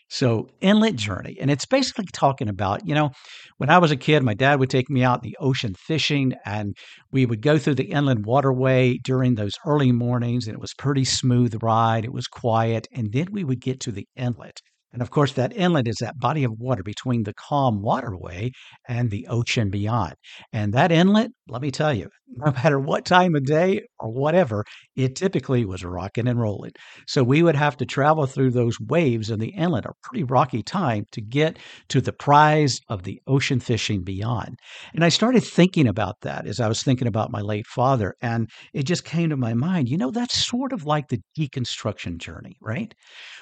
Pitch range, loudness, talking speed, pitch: 115-150 Hz, -22 LUFS, 210 wpm, 130 Hz